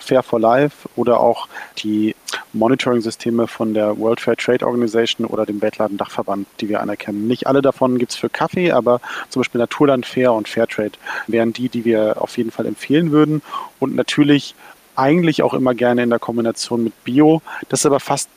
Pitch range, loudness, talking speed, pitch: 115-135 Hz, -18 LUFS, 185 wpm, 120 Hz